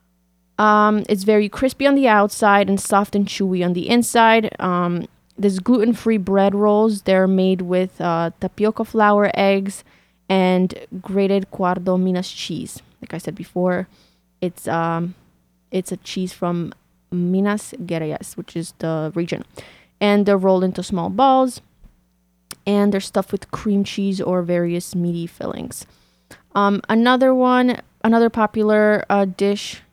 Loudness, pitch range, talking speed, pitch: -18 LUFS, 175-210 Hz, 140 wpm, 195 Hz